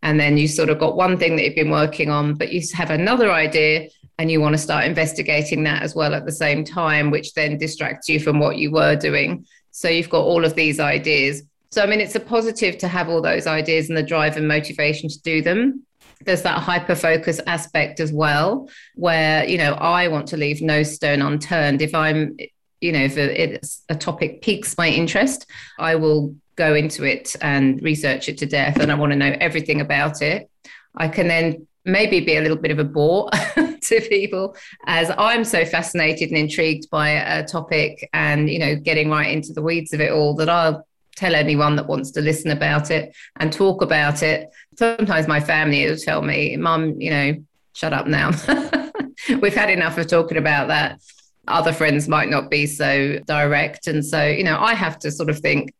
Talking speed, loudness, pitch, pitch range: 210 wpm, -19 LUFS, 155 Hz, 150-170 Hz